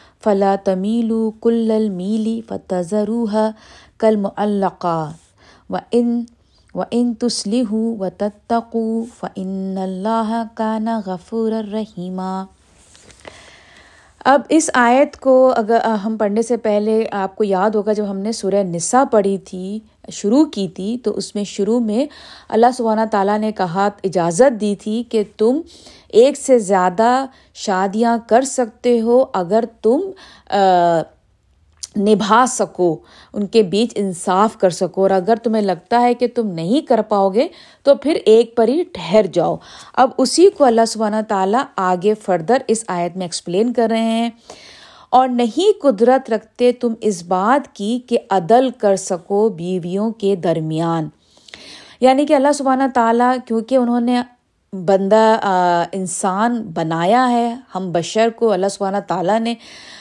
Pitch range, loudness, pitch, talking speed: 195-240 Hz, -17 LUFS, 220 Hz, 145 wpm